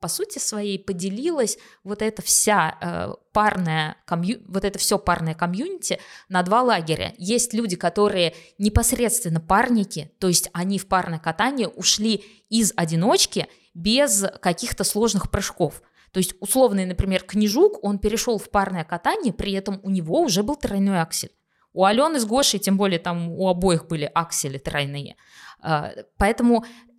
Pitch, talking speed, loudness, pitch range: 195 Hz, 150 wpm, -22 LUFS, 175-220 Hz